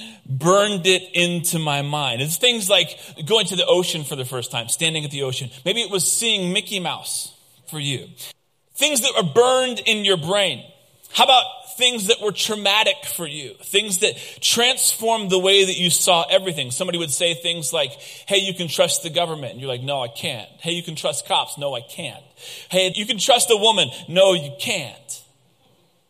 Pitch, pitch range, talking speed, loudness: 180 Hz, 150-210 Hz, 200 wpm, -19 LUFS